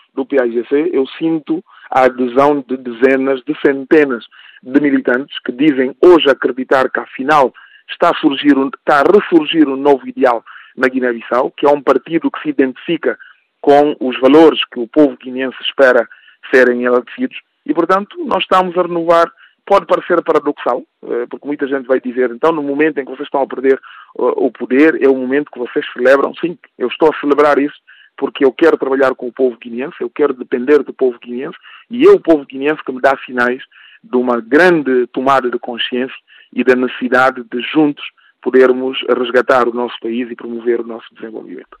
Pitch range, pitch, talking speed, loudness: 125-160 Hz, 135 Hz, 185 wpm, -14 LUFS